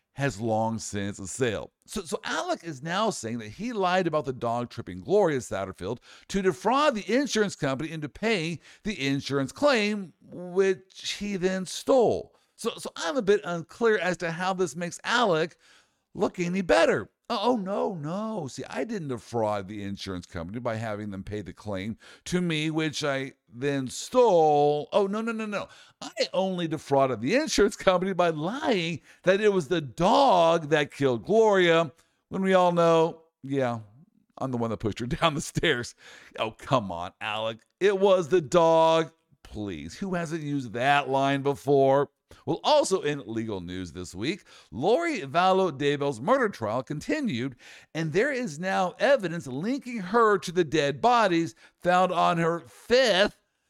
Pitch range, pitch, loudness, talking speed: 135-190 Hz, 165 Hz, -26 LUFS, 165 wpm